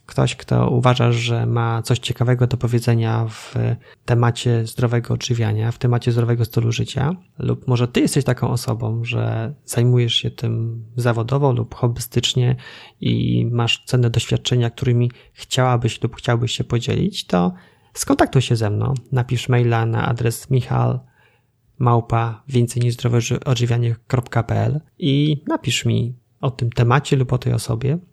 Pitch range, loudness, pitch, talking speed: 115-125 Hz, -20 LUFS, 120 Hz, 130 wpm